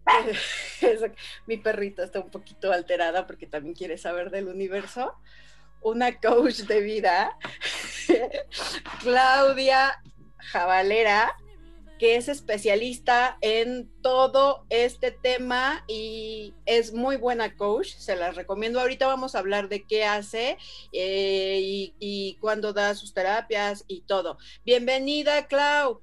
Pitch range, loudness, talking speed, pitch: 195-255 Hz, -25 LUFS, 120 wpm, 220 Hz